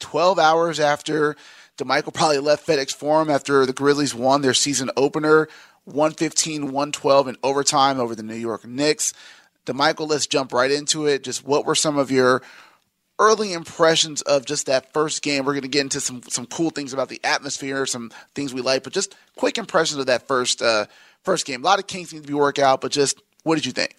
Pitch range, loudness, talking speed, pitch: 135-155 Hz, -20 LUFS, 210 wpm, 145 Hz